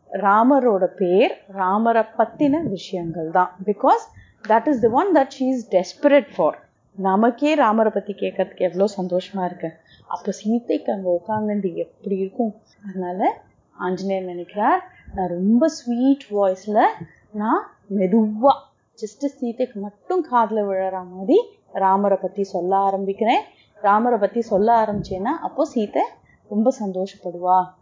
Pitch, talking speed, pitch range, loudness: 205 Hz, 120 wpm, 190-240 Hz, -21 LUFS